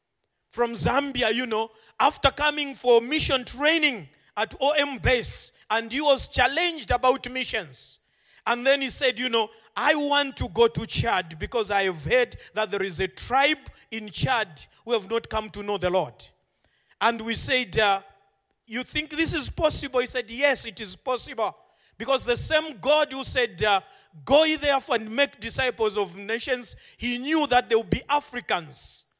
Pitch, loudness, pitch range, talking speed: 245 Hz, -23 LUFS, 215-280 Hz, 175 wpm